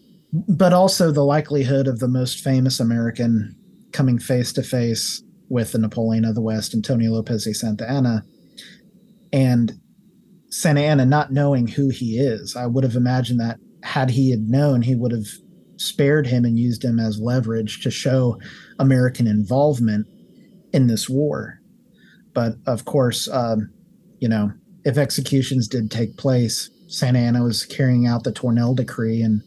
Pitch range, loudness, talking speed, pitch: 115-145 Hz, -20 LUFS, 160 wpm, 125 Hz